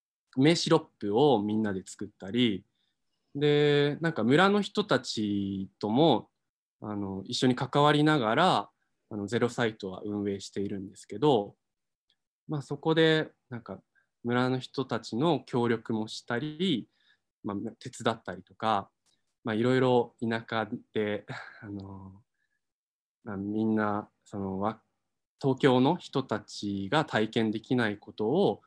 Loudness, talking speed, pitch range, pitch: -29 LUFS, 250 characters per minute, 105-135 Hz, 115 Hz